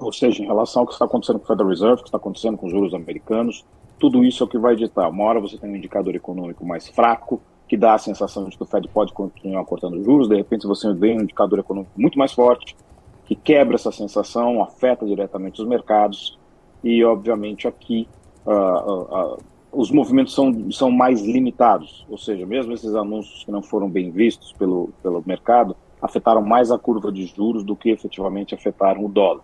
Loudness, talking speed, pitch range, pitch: -20 LUFS, 210 wpm, 100-120 Hz, 105 Hz